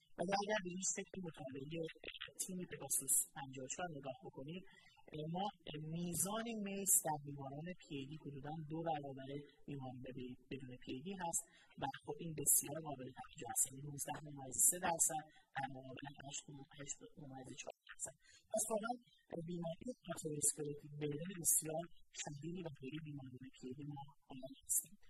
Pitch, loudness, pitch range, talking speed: 150 Hz, -42 LUFS, 140-175 Hz, 120 wpm